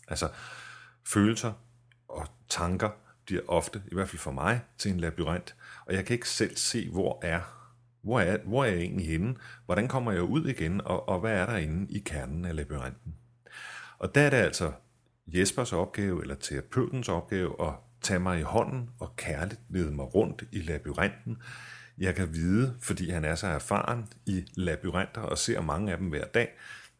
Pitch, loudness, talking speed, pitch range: 95 Hz, -31 LUFS, 185 wpm, 85-115 Hz